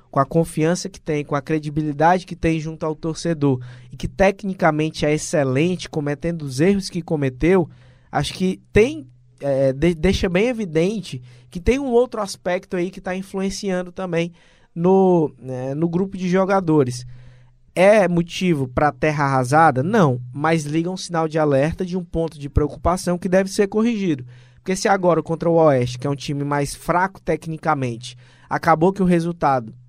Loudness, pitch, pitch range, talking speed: -20 LUFS, 165 Hz, 145-185 Hz, 170 wpm